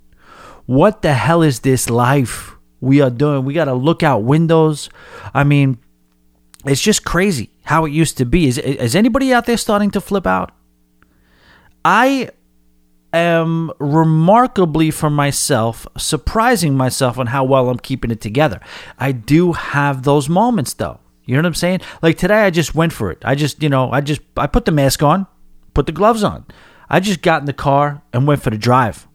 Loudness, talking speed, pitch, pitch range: -15 LUFS, 185 wpm, 145 Hz, 125-165 Hz